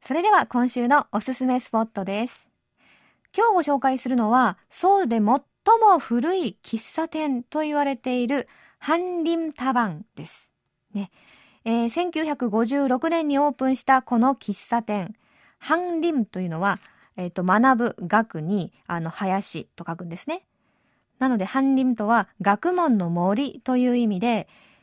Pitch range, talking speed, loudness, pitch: 210-290 Hz, 275 characters per minute, -23 LUFS, 250 Hz